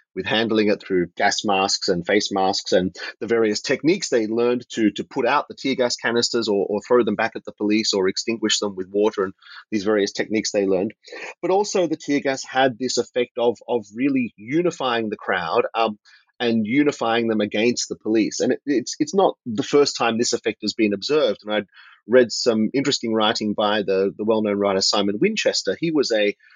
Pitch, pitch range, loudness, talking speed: 110 Hz, 105-125 Hz, -21 LUFS, 210 wpm